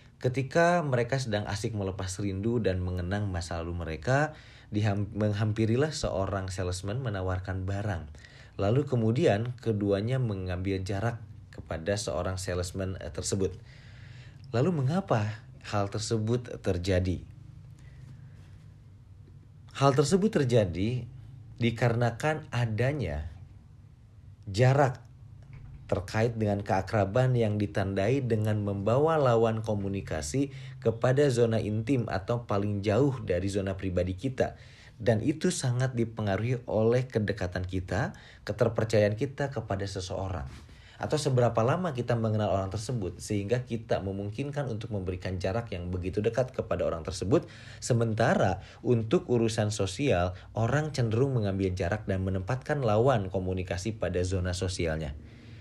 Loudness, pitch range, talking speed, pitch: -29 LUFS, 100-125 Hz, 110 wpm, 110 Hz